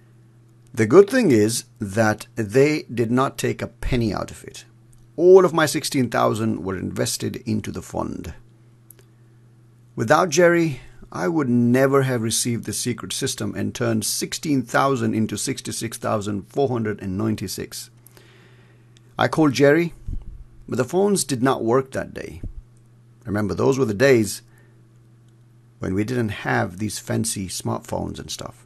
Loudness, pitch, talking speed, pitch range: -21 LUFS, 120 Hz, 130 wpm, 115-130 Hz